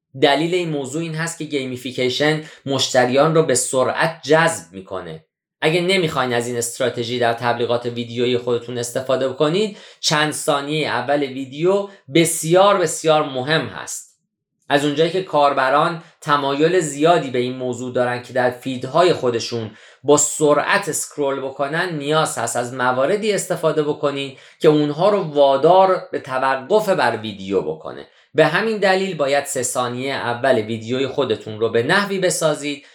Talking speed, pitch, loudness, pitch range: 140 wpm, 145 Hz, -19 LUFS, 125-160 Hz